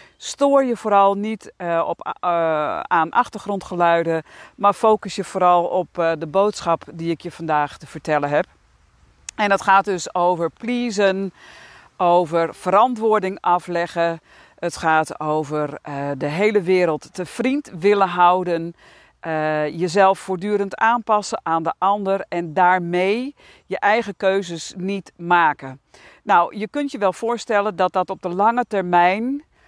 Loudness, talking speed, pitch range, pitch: -20 LUFS, 140 wpm, 165-205 Hz, 185 Hz